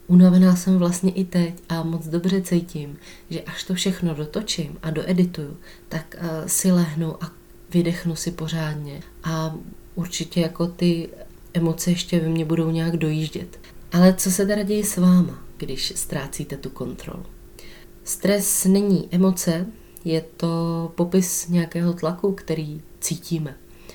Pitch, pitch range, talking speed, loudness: 170 Hz, 160-180 Hz, 140 wpm, -22 LUFS